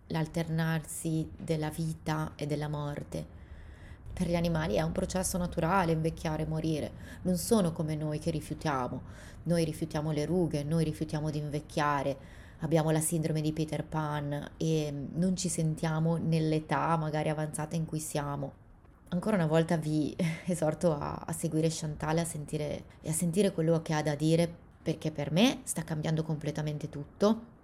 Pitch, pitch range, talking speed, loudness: 155 Hz, 150-165 Hz, 150 wpm, -32 LUFS